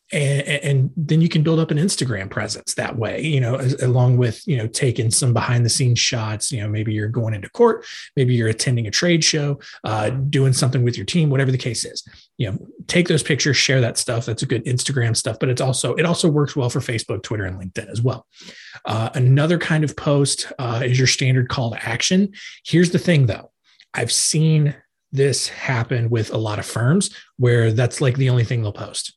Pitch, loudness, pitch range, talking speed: 130 Hz, -19 LUFS, 115-145 Hz, 220 wpm